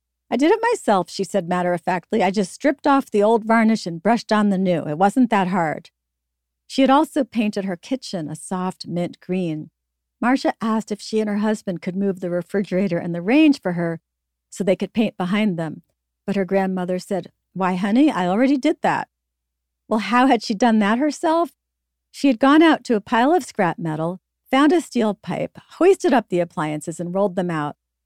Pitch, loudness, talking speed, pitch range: 200 Hz, -20 LUFS, 205 wpm, 175-240 Hz